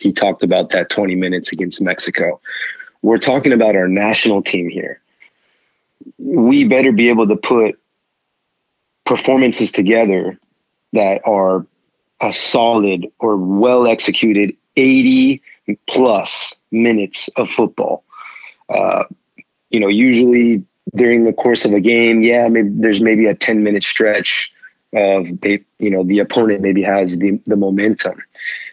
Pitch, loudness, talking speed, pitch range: 110 Hz, -14 LUFS, 125 wpm, 100-120 Hz